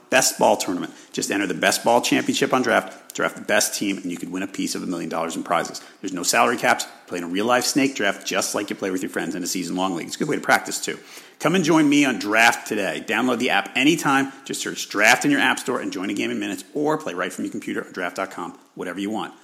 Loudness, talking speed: -21 LUFS, 285 wpm